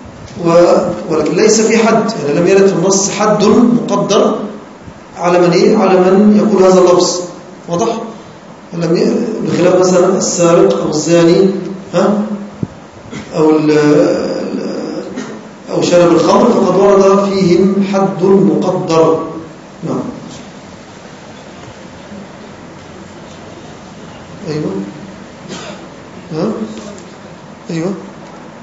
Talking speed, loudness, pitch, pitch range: 85 wpm, -11 LUFS, 185 Hz, 175-200 Hz